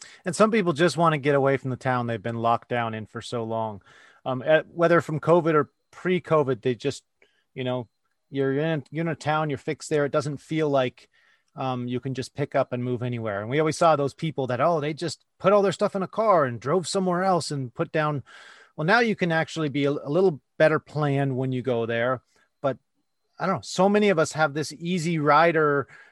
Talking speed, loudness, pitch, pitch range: 235 wpm, -24 LUFS, 150 Hz, 130-165 Hz